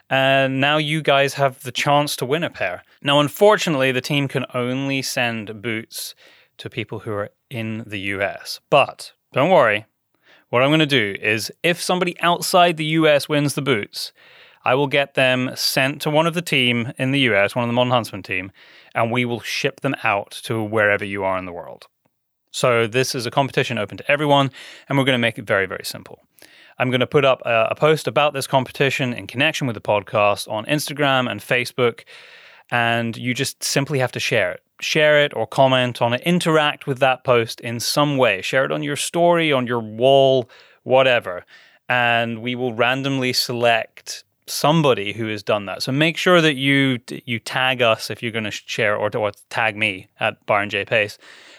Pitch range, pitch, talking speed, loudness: 115-145 Hz, 130 Hz, 200 wpm, -19 LUFS